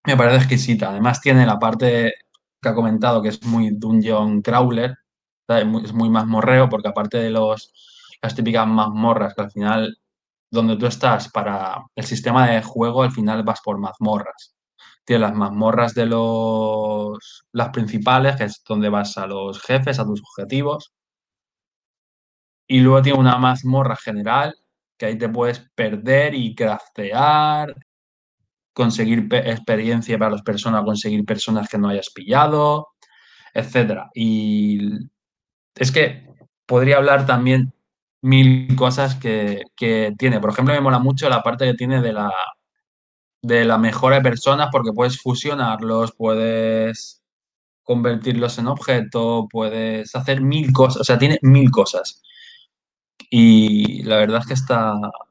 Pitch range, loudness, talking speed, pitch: 110-130 Hz, -18 LUFS, 145 wpm, 115 Hz